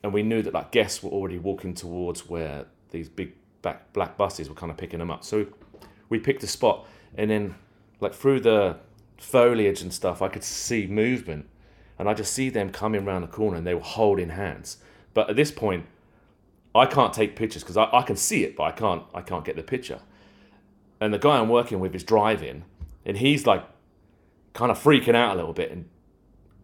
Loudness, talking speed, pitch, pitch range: -25 LUFS, 210 wpm, 105 Hz, 90-110 Hz